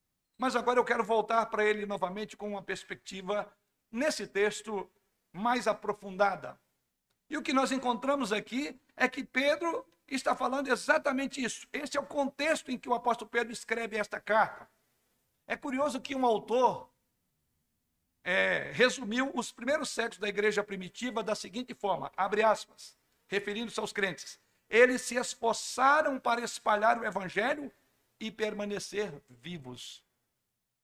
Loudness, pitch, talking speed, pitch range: -31 LUFS, 230 Hz, 140 wpm, 205-255 Hz